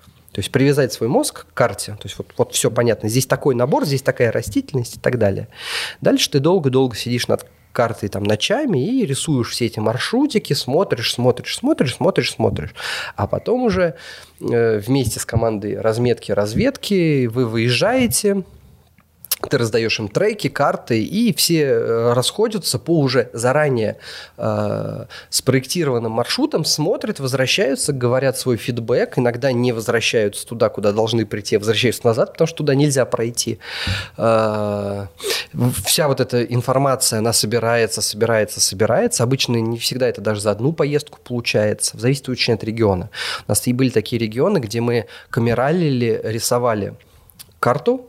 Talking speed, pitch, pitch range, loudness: 145 wpm, 125 Hz, 115-140 Hz, -19 LUFS